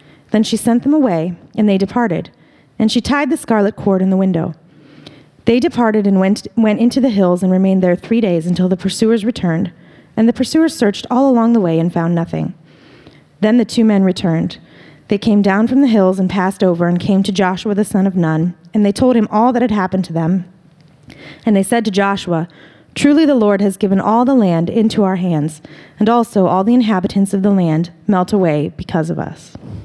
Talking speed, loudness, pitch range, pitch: 215 wpm, -14 LUFS, 175-225 Hz, 195 Hz